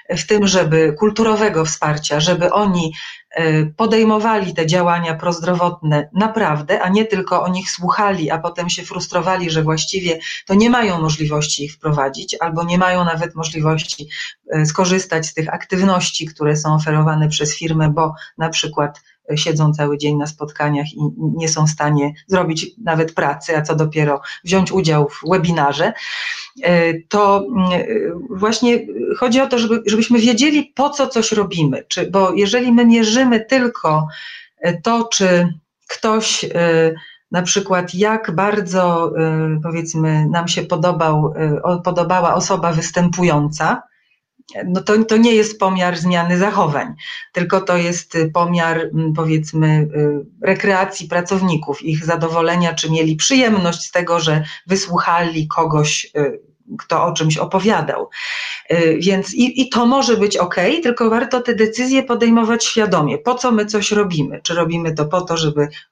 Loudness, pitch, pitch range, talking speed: -16 LUFS, 175 Hz, 160-205 Hz, 135 wpm